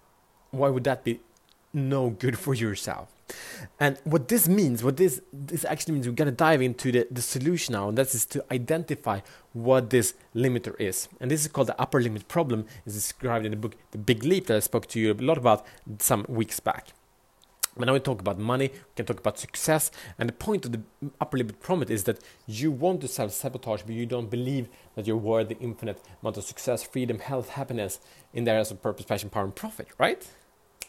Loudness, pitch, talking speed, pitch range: -27 LUFS, 125 Hz, 220 wpm, 110-140 Hz